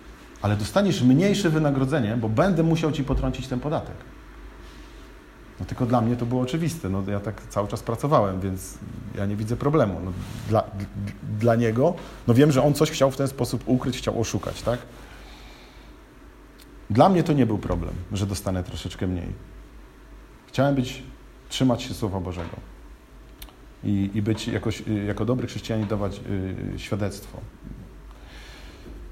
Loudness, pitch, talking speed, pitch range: -24 LUFS, 110 Hz, 145 wpm, 100-130 Hz